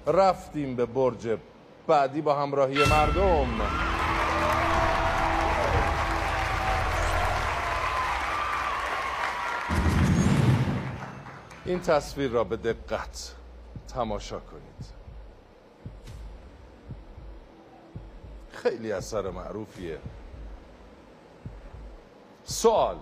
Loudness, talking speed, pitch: -26 LUFS, 45 wpm, 95 Hz